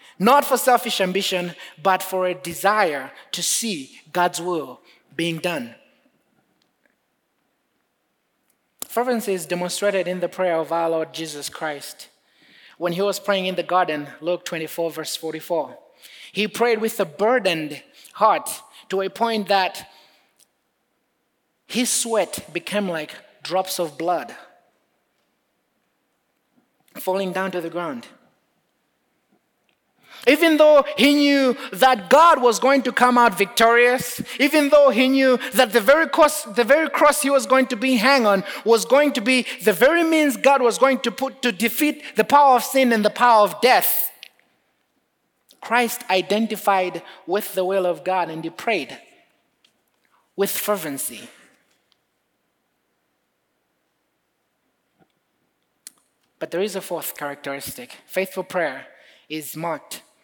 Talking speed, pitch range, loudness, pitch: 130 wpm, 175-255 Hz, -20 LUFS, 205 Hz